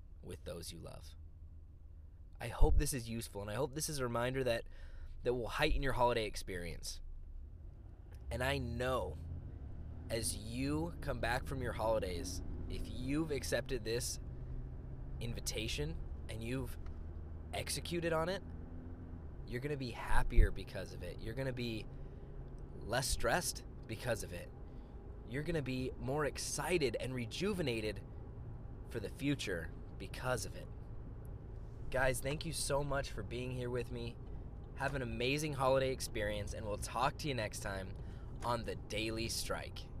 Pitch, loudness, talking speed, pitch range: 110 Hz, -40 LUFS, 150 wpm, 85-125 Hz